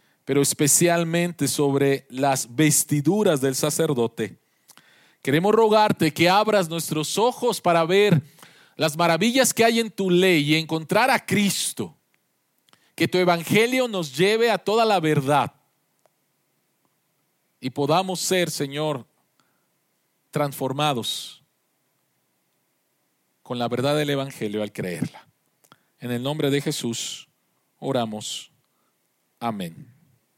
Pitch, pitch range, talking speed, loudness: 155 Hz, 140-185 Hz, 105 wpm, -22 LUFS